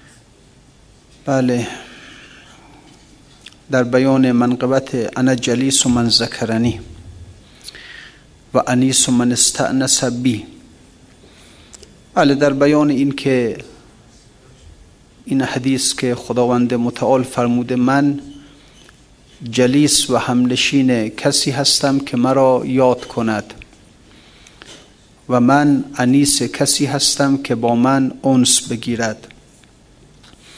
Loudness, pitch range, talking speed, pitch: -15 LUFS, 120-135 Hz, 90 wpm, 130 Hz